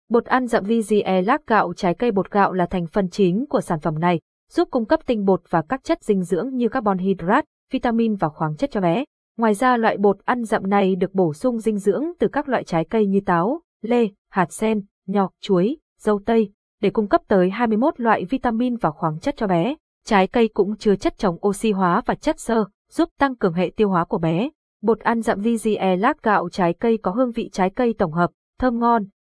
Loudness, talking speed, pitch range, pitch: -21 LUFS, 230 wpm, 190-245 Hz, 215 Hz